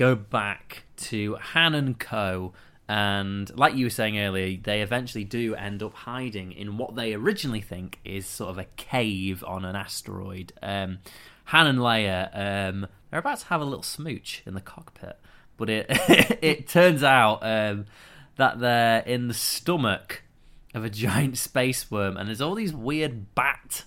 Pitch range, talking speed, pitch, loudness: 100-130 Hz, 170 wpm, 110 Hz, -25 LUFS